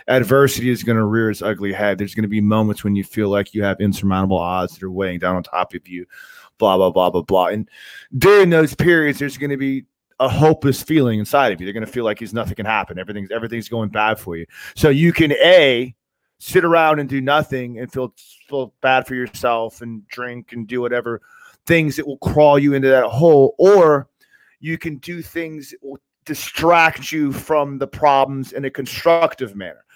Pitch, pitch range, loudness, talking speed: 125 Hz, 105-145 Hz, -17 LUFS, 210 wpm